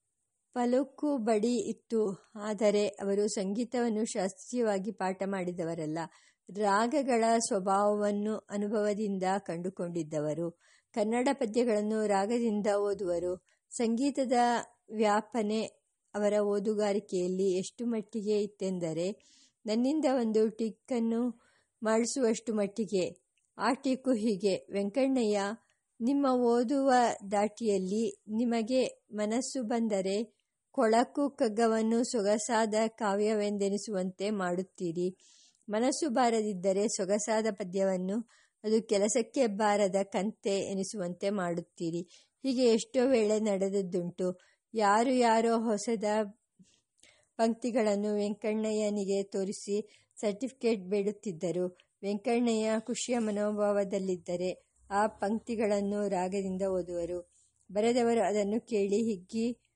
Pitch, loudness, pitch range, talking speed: 210 Hz, -31 LUFS, 195-230 Hz, 75 wpm